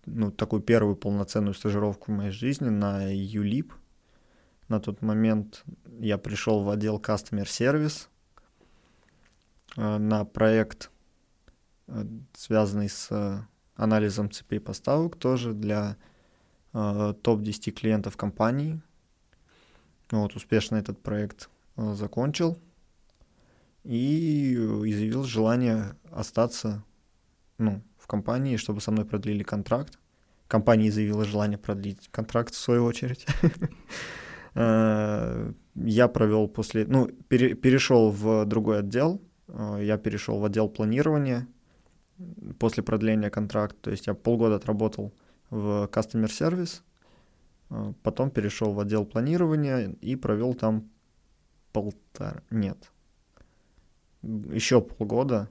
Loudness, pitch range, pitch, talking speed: -27 LUFS, 105-115 Hz, 110 Hz, 100 wpm